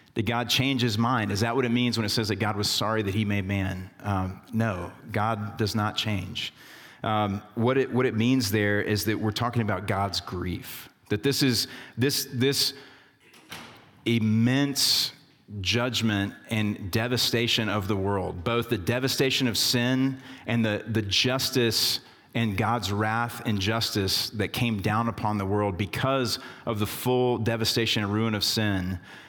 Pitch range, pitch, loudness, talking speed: 105-125 Hz, 115 Hz, -26 LUFS, 170 wpm